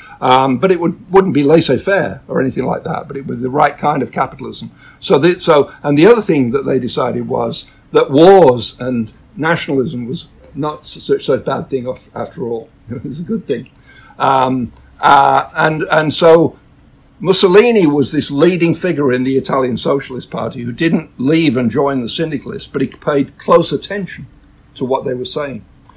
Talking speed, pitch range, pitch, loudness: 185 wpm, 130-170 Hz, 145 Hz, -14 LUFS